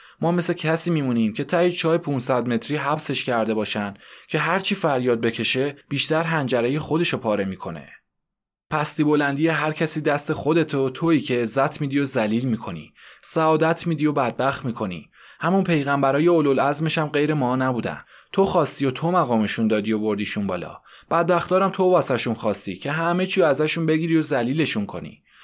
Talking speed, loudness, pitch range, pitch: 165 wpm, -22 LUFS, 125-165 Hz, 145 Hz